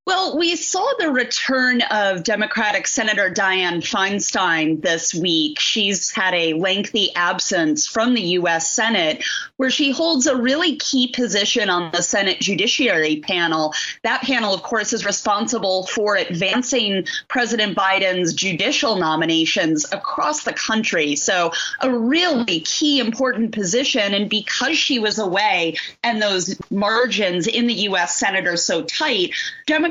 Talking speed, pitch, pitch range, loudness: 140 wpm, 215 Hz, 185-260 Hz, -18 LUFS